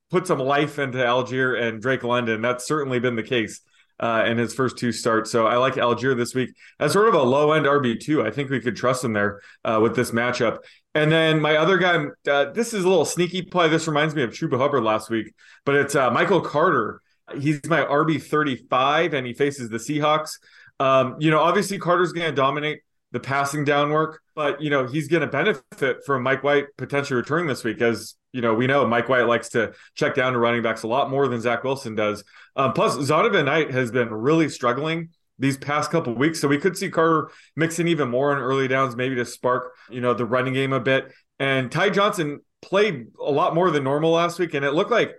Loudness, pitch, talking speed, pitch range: -22 LUFS, 140 Hz, 230 wpm, 125-155 Hz